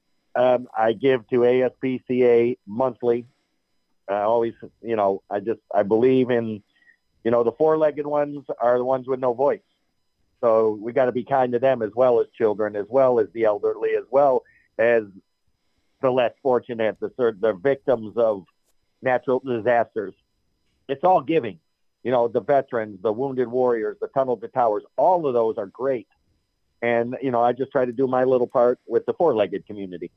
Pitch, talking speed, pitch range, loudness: 125 Hz, 180 wpm, 115-135 Hz, -22 LUFS